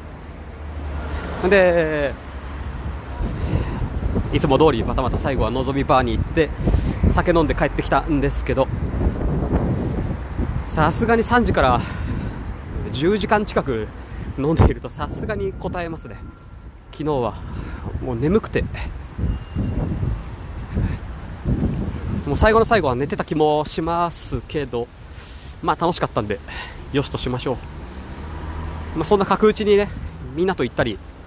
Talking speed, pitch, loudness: 235 characters per minute, 110 Hz, -21 LUFS